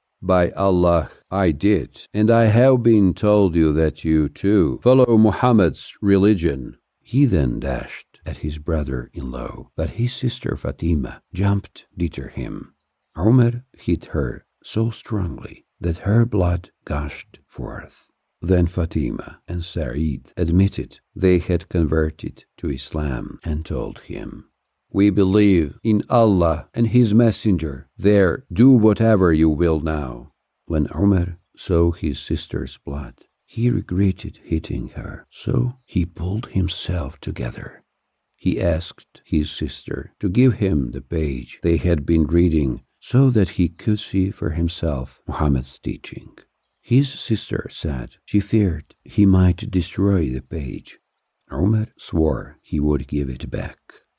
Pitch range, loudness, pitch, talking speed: 80-105 Hz, -20 LUFS, 90 Hz, 135 wpm